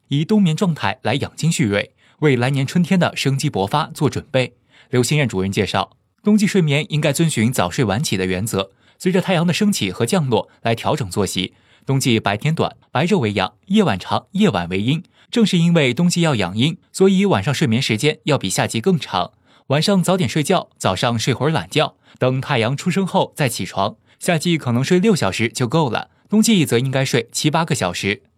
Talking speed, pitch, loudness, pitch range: 300 characters per minute, 145 Hz, -18 LUFS, 115-175 Hz